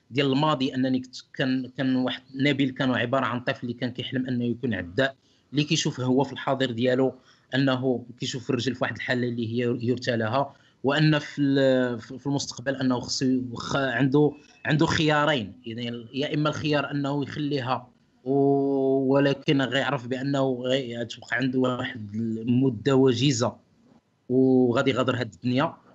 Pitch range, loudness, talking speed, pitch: 125-140 Hz, -25 LUFS, 140 wpm, 130 Hz